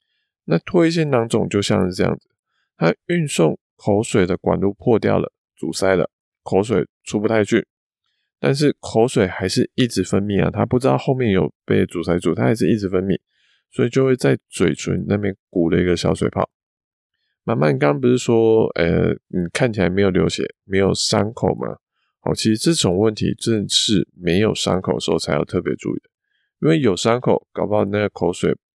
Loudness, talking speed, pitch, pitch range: -19 LUFS, 280 characters per minute, 105 Hz, 95-120 Hz